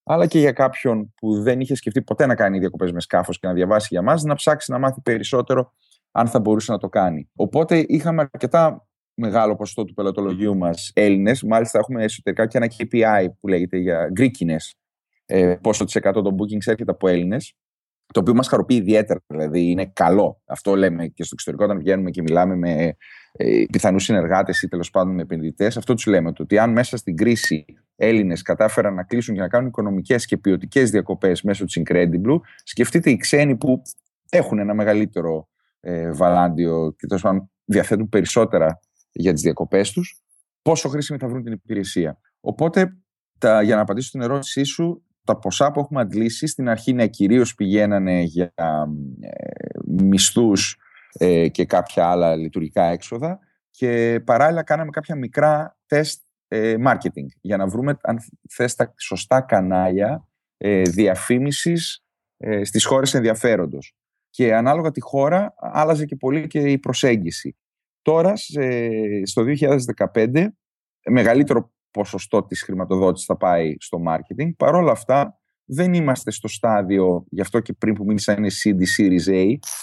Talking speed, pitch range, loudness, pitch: 160 wpm, 95-130 Hz, -20 LUFS, 110 Hz